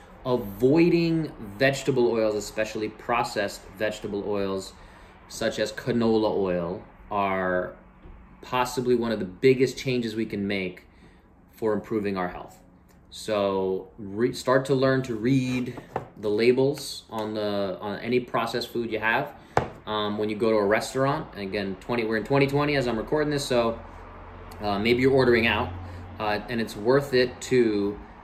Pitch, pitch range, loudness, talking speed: 110 Hz, 100-125 Hz, -26 LUFS, 150 wpm